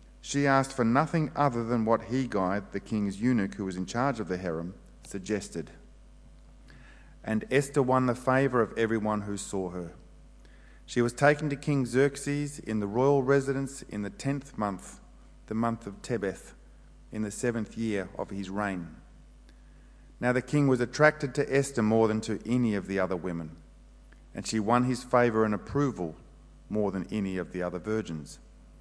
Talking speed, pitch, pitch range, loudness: 175 wpm, 115 Hz, 100-135 Hz, -29 LUFS